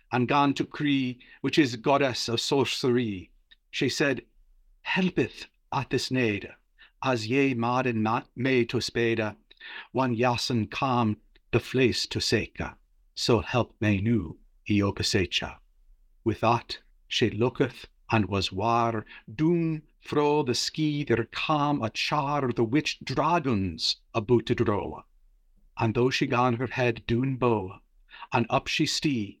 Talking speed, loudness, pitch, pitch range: 135 wpm, -27 LUFS, 120 Hz, 115-135 Hz